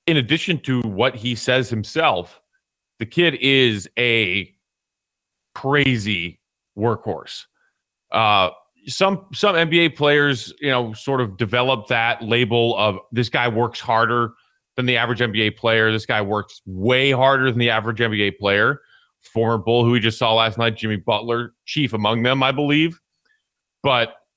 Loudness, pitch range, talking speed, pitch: -19 LUFS, 110-135 Hz, 150 wpm, 120 Hz